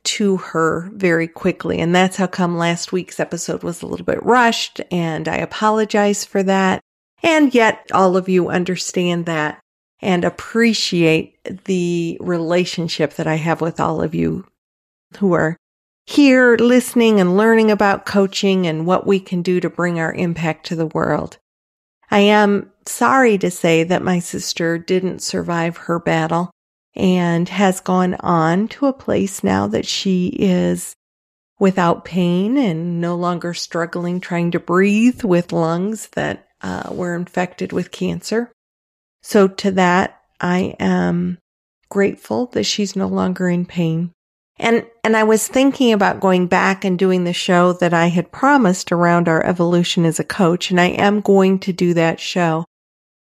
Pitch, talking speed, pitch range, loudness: 180 Hz, 160 wpm, 170-200 Hz, -17 LUFS